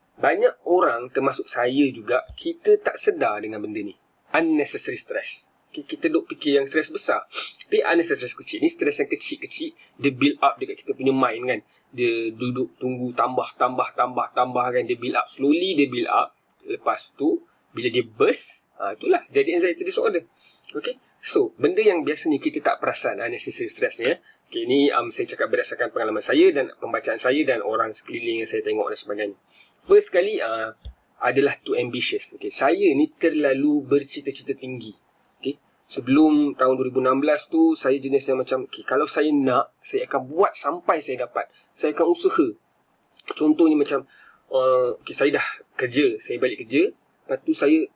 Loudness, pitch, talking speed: -23 LUFS, 345 Hz, 175 wpm